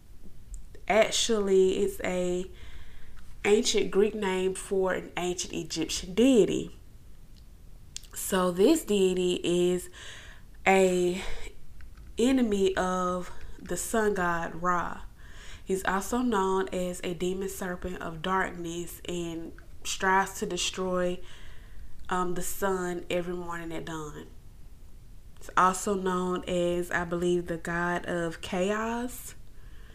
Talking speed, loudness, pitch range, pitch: 105 wpm, -28 LUFS, 175-190 Hz, 180 Hz